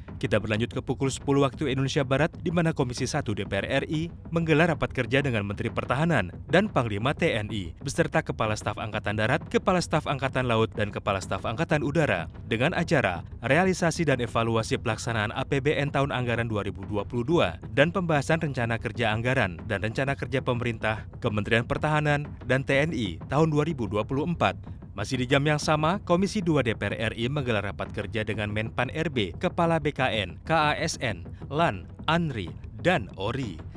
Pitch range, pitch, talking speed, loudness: 110-150 Hz, 130 Hz, 150 wpm, -27 LUFS